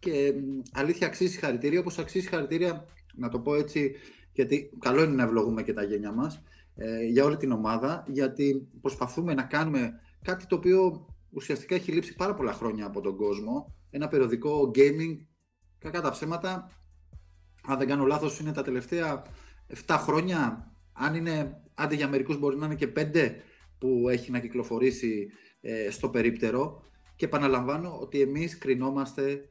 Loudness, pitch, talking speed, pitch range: -29 LUFS, 135 Hz, 165 wpm, 115-155 Hz